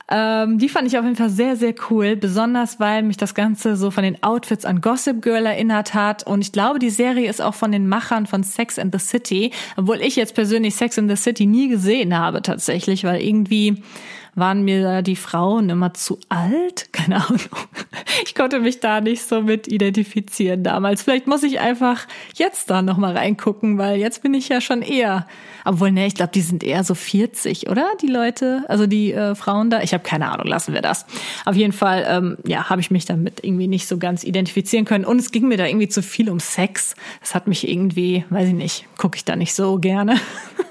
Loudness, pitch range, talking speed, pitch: -19 LUFS, 190-230 Hz, 220 wpm, 210 Hz